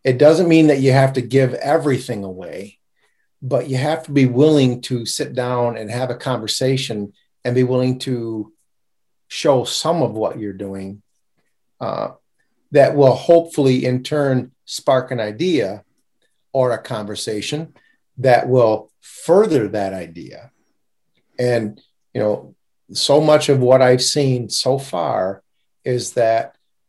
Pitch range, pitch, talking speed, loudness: 120-135 Hz, 130 Hz, 140 wpm, -17 LUFS